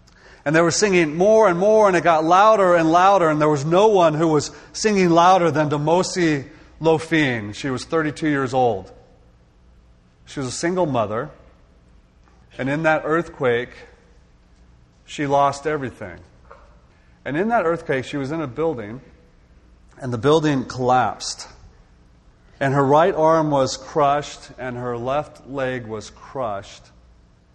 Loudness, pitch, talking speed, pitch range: -19 LUFS, 140 Hz, 145 wpm, 105-160 Hz